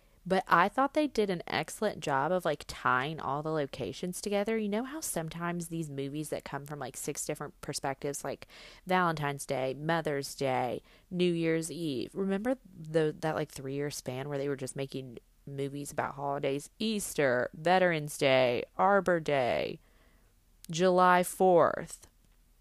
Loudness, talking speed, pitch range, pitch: -31 LUFS, 155 wpm, 140-180 Hz, 155 Hz